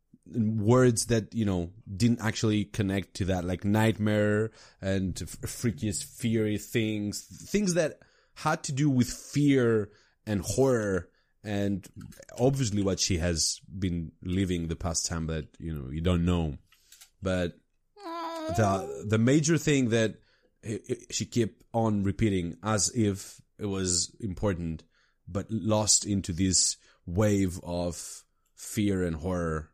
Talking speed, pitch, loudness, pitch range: 130 wpm, 105 Hz, -28 LUFS, 90-115 Hz